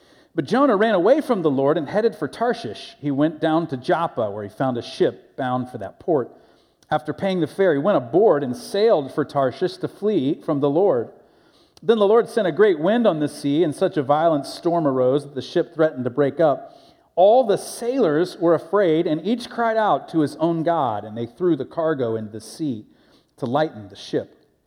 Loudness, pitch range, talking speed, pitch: -21 LUFS, 140-200 Hz, 215 wpm, 160 Hz